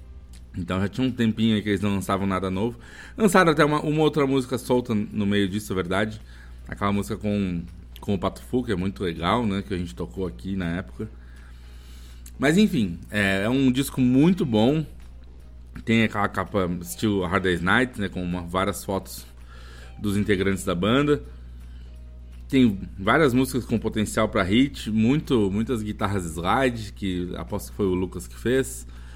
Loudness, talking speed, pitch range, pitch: -24 LUFS, 175 wpm, 85-115 Hz, 100 Hz